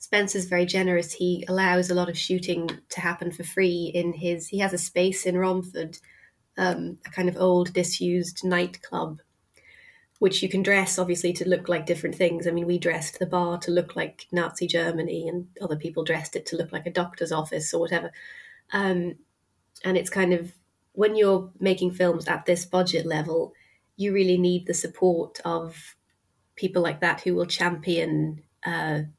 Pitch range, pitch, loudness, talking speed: 170-185 Hz, 175 Hz, -25 LUFS, 180 wpm